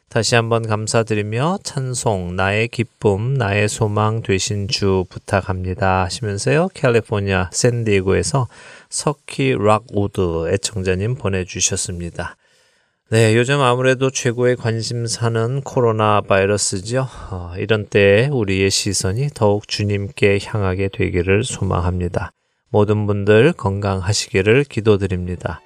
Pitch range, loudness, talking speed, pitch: 95-120 Hz, -18 LUFS, 285 characters per minute, 105 Hz